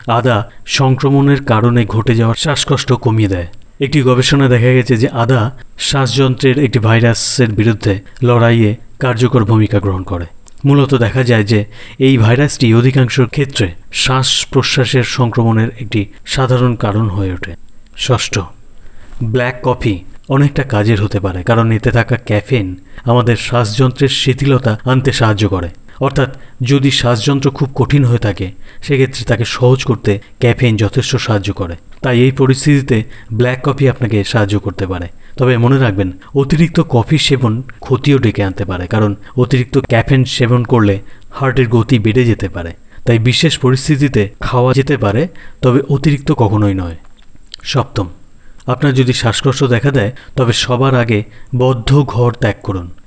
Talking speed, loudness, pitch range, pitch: 140 wpm, -13 LUFS, 105-130 Hz, 120 Hz